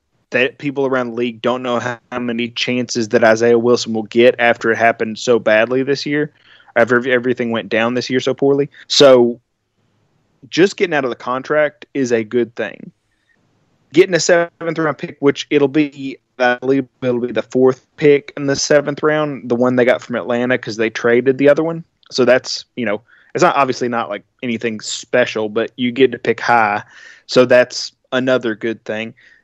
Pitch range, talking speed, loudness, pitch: 120-140 Hz, 190 wpm, -16 LUFS, 125 Hz